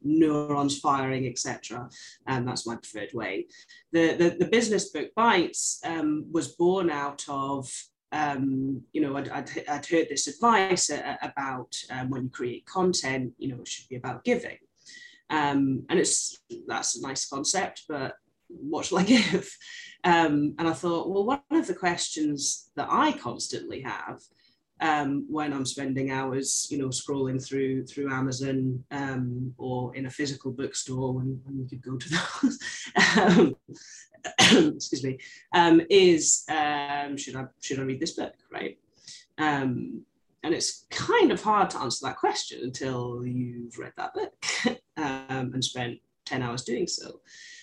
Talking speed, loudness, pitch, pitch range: 160 wpm, -27 LUFS, 145 Hz, 130-195 Hz